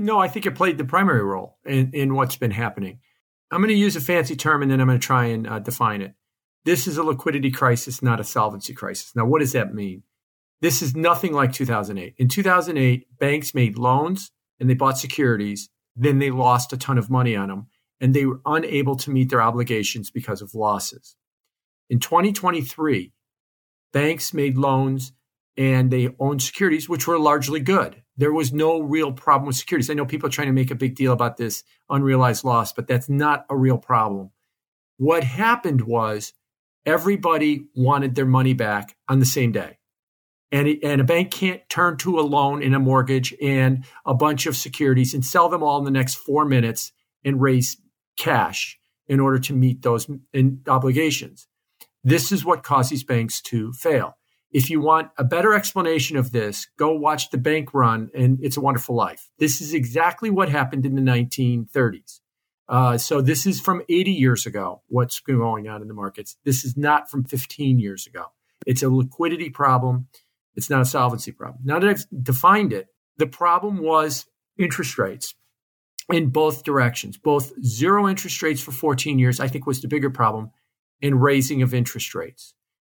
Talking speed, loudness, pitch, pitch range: 190 wpm, -21 LUFS, 135 Hz, 125-150 Hz